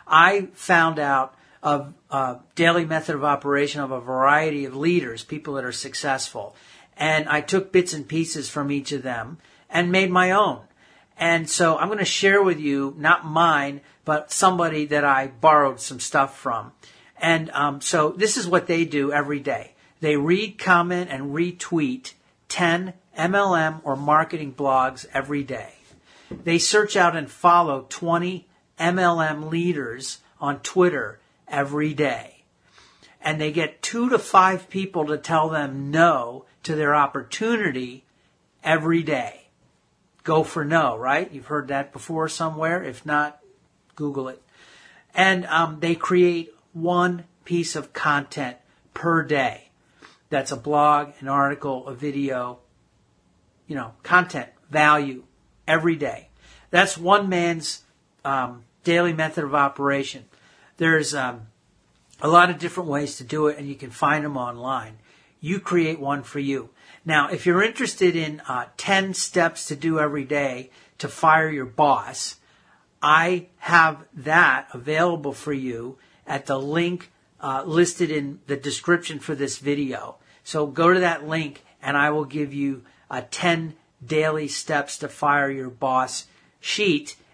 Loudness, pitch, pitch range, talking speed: -22 LUFS, 155 Hz, 140-170 Hz, 150 wpm